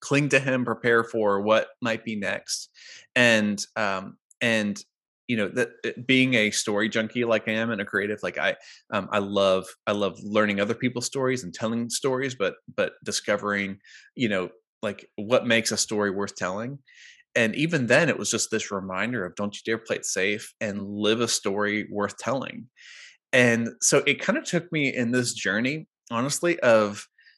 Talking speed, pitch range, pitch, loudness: 185 wpm, 105-125 Hz, 110 Hz, -25 LUFS